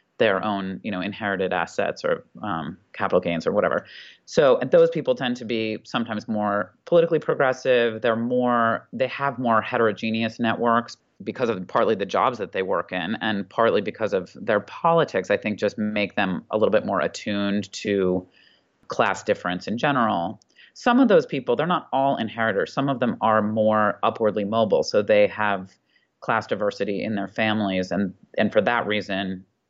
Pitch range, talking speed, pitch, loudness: 100-130 Hz, 180 wpm, 110 Hz, -23 LUFS